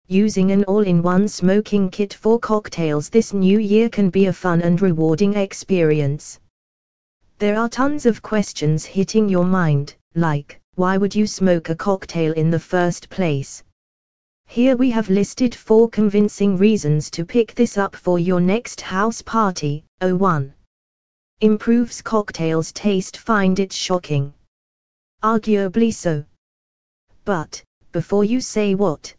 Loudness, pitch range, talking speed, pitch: -19 LUFS, 155-210 Hz, 140 wpm, 190 Hz